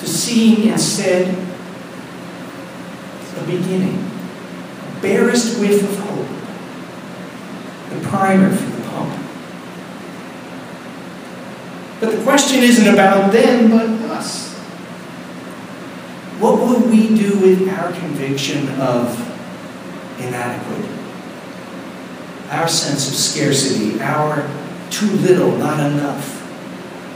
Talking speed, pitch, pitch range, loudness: 90 wpm, 190 Hz, 160-220 Hz, -16 LUFS